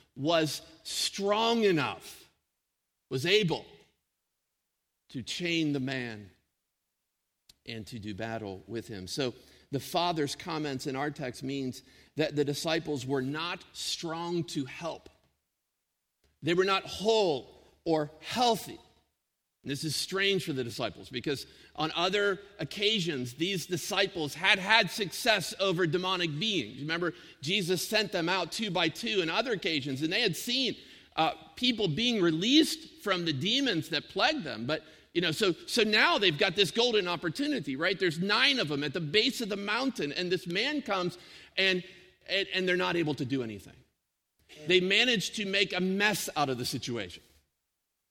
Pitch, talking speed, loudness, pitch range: 175 Hz, 155 wpm, -29 LUFS, 145-200 Hz